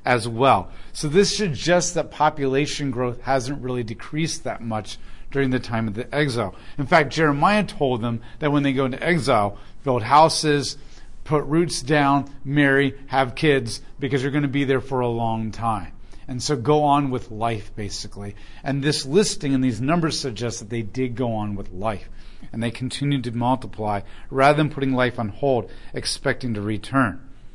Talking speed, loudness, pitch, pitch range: 180 wpm, -22 LUFS, 130 Hz, 115-145 Hz